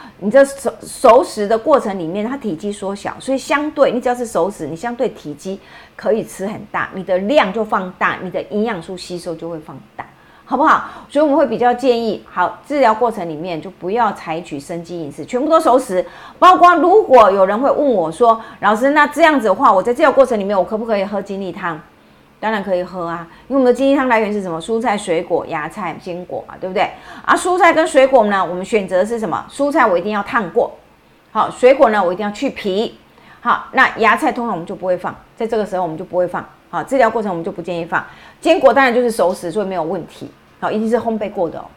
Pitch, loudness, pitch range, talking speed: 210 Hz, -16 LUFS, 180-255 Hz, 350 characters per minute